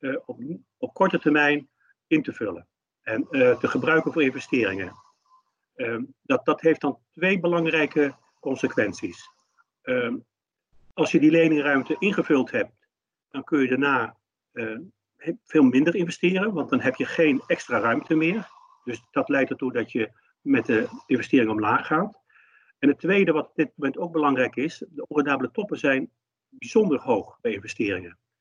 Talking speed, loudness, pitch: 155 wpm, -24 LUFS, 165 Hz